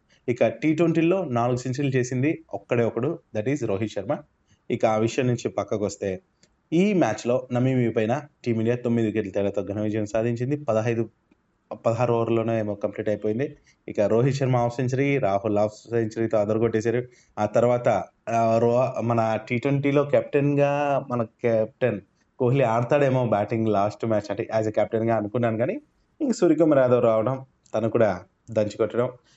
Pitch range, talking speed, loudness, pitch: 110-130 Hz, 145 wpm, -24 LUFS, 120 Hz